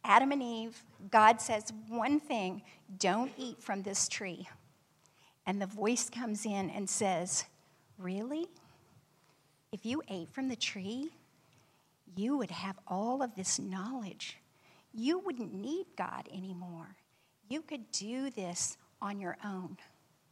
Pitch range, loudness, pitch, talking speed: 185-240 Hz, -35 LUFS, 205 Hz, 135 wpm